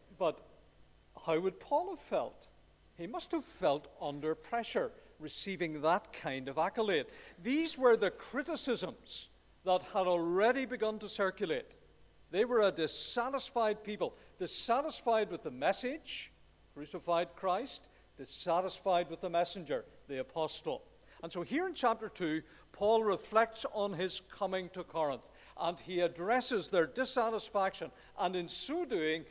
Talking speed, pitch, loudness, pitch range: 135 wpm, 200 Hz, -35 LUFS, 175-250 Hz